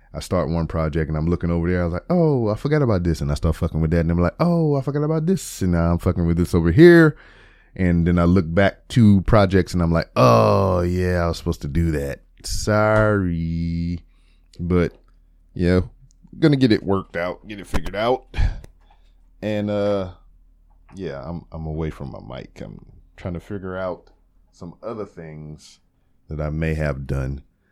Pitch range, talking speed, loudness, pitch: 80-100 Hz, 195 wpm, -20 LUFS, 85 Hz